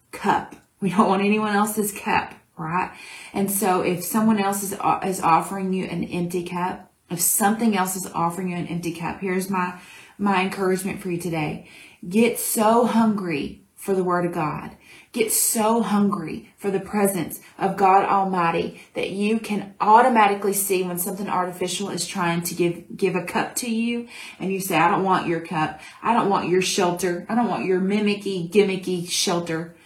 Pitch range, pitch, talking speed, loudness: 180-205 Hz, 190 Hz, 180 wpm, -22 LUFS